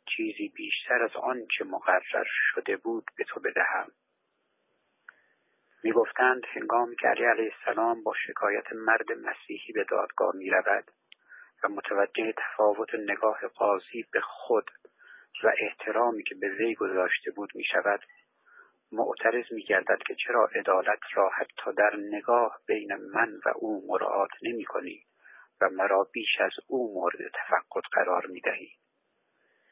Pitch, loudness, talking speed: 340 Hz, -28 LUFS, 135 wpm